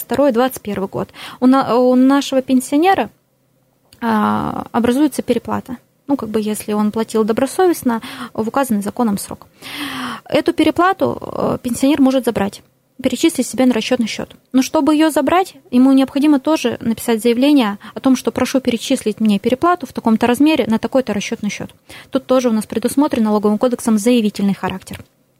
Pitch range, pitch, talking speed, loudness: 220-270 Hz, 245 Hz, 140 wpm, -16 LUFS